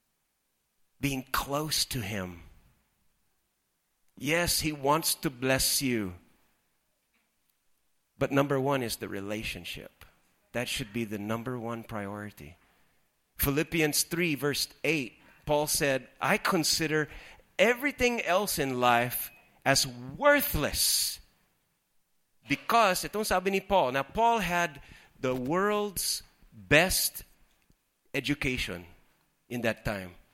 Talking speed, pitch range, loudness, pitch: 100 wpm, 110-155 Hz, -28 LUFS, 135 Hz